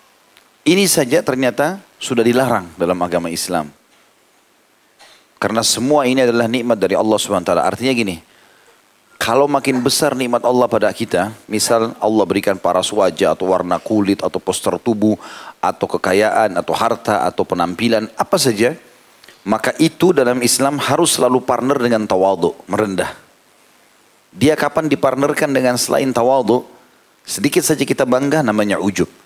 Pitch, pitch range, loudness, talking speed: 125 Hz, 110-140 Hz, -16 LUFS, 135 wpm